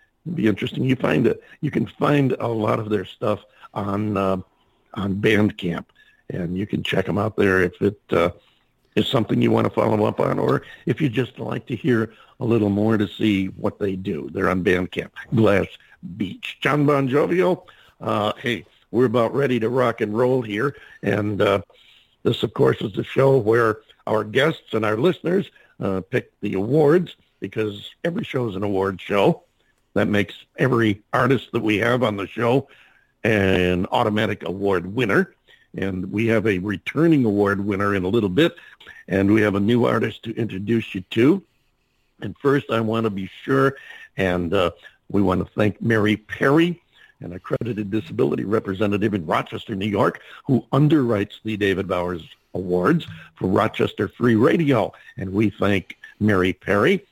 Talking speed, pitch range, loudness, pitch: 175 wpm, 100-125 Hz, -21 LUFS, 110 Hz